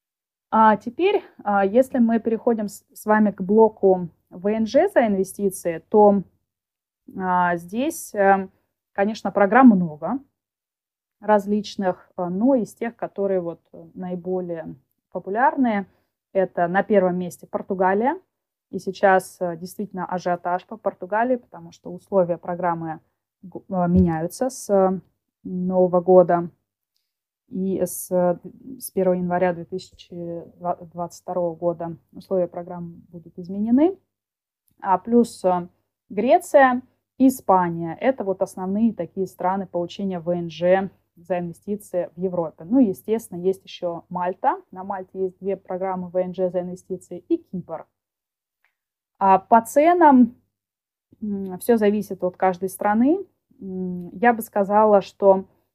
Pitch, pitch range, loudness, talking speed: 190 Hz, 180-215 Hz, -21 LUFS, 105 wpm